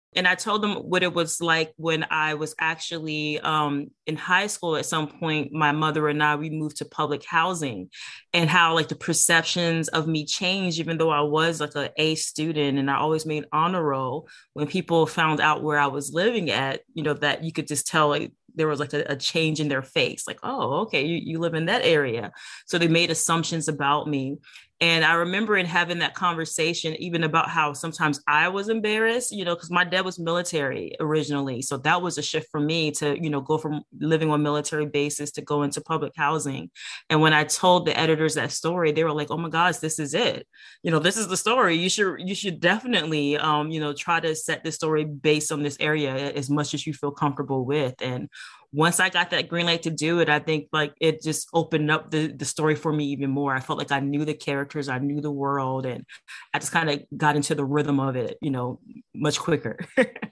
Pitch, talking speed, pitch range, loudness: 155 Hz, 230 wpm, 150-165 Hz, -24 LUFS